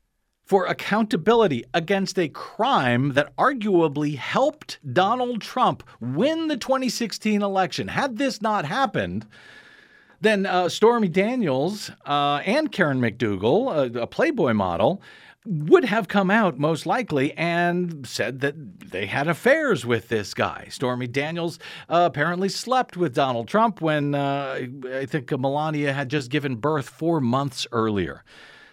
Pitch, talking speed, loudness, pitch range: 170 Hz, 135 wpm, -23 LUFS, 140-210 Hz